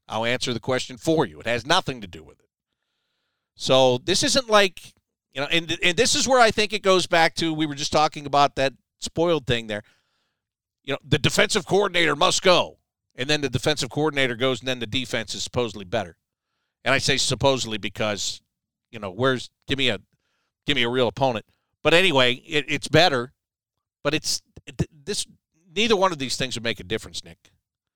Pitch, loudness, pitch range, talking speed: 135 Hz, -22 LUFS, 115-165 Hz, 200 wpm